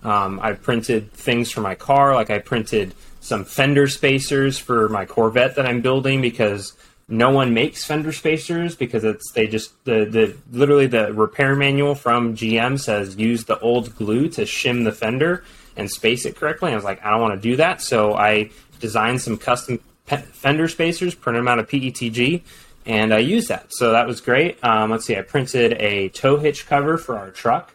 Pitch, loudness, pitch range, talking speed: 120 Hz, -19 LUFS, 110-140 Hz, 195 wpm